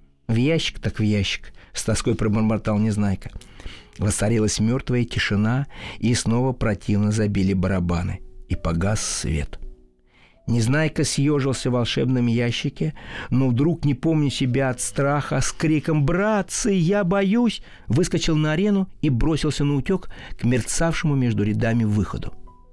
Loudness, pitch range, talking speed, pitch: -22 LUFS, 105-150 Hz, 130 wpm, 120 Hz